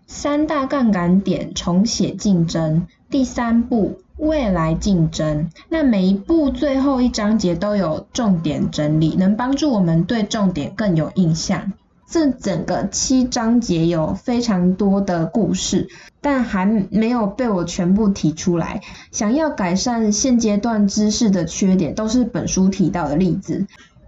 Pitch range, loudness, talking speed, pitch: 175-240 Hz, -18 LUFS, 220 characters per minute, 200 Hz